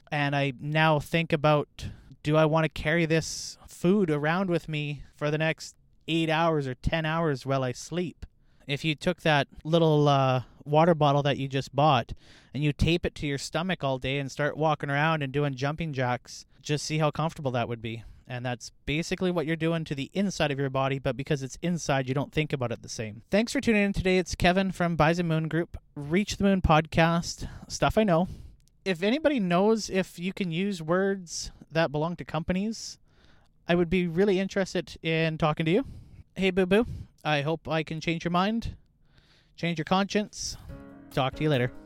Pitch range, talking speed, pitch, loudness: 140-175 Hz, 200 wpm, 155 Hz, -27 LUFS